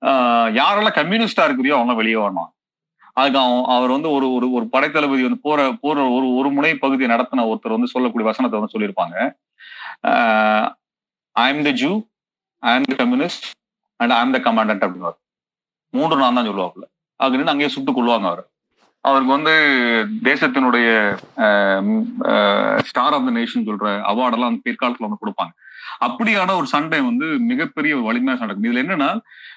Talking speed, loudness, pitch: 125 wpm, -18 LUFS, 135 Hz